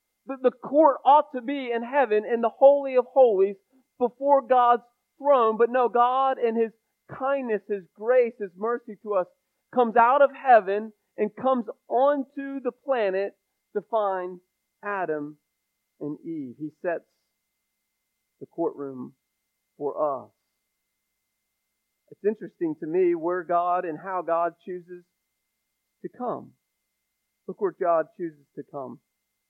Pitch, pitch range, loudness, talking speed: 235 Hz, 190-270 Hz, -24 LUFS, 130 wpm